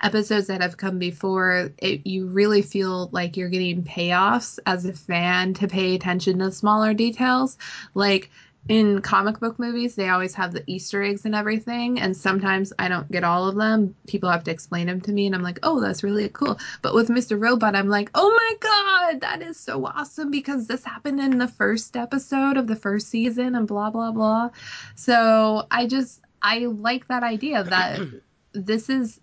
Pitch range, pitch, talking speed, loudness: 190-240 Hz, 210 Hz, 195 wpm, -22 LUFS